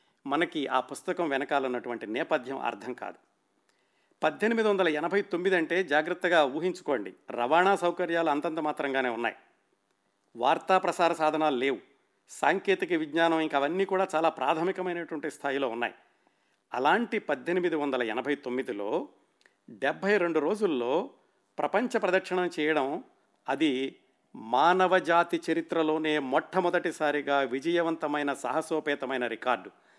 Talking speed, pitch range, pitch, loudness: 100 wpm, 145-180 Hz, 160 Hz, -28 LUFS